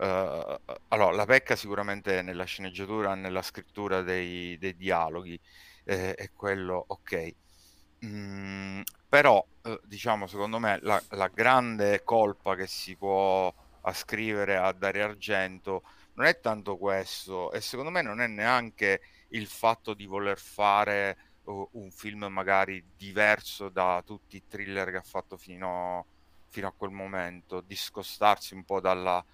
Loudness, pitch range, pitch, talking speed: -29 LUFS, 95-100 Hz, 95 Hz, 145 wpm